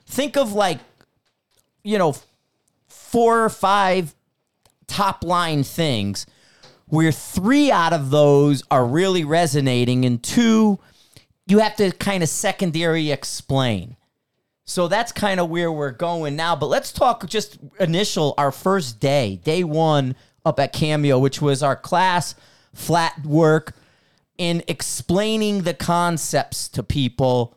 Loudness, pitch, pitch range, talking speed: -20 LUFS, 160 Hz, 140-185 Hz, 135 wpm